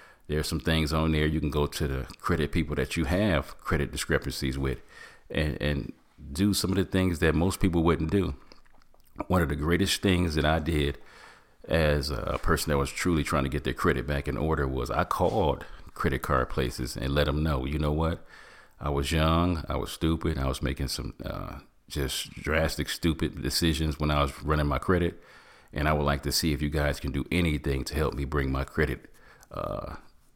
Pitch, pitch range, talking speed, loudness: 75 Hz, 70-80 Hz, 210 wpm, -28 LUFS